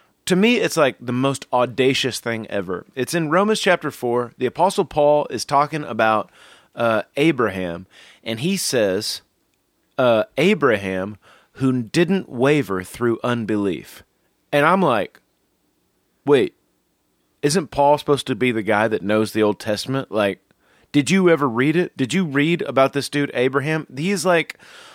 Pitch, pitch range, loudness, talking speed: 135 Hz, 115-155 Hz, -20 LUFS, 150 wpm